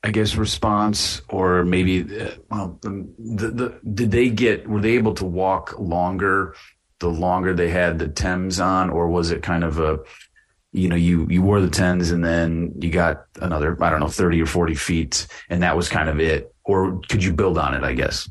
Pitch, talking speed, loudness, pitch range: 90 Hz, 205 wpm, -21 LUFS, 85-100 Hz